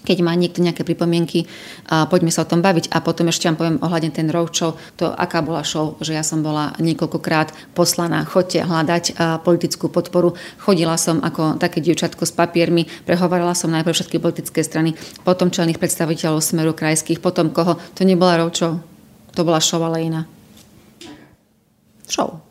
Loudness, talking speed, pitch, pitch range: -18 LUFS, 165 wpm, 170 Hz, 160-175 Hz